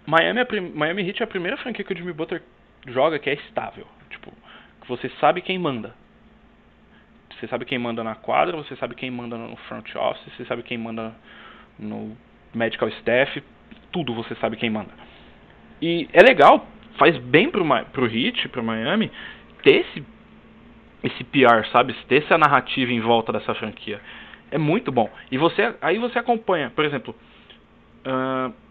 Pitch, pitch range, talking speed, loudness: 130 Hz, 115-185 Hz, 165 wpm, -21 LUFS